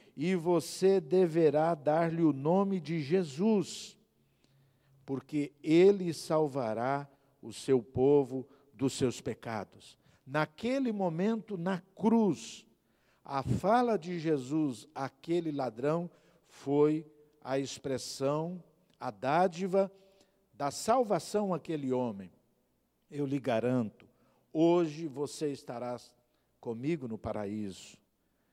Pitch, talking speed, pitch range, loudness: 155 Hz, 95 wpm, 135-180 Hz, -32 LUFS